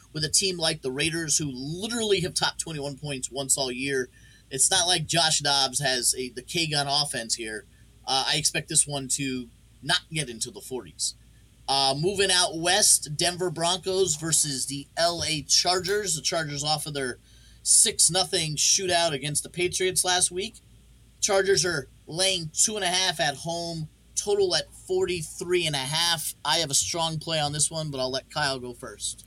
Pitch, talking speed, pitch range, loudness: 155 Hz, 185 wpm, 135-180 Hz, -24 LUFS